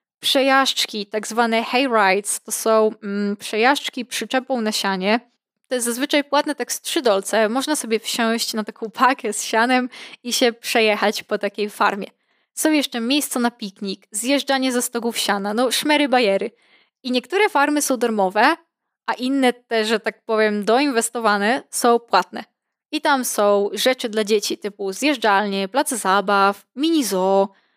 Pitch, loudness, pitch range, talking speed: 235 Hz, -19 LUFS, 210-260 Hz, 155 wpm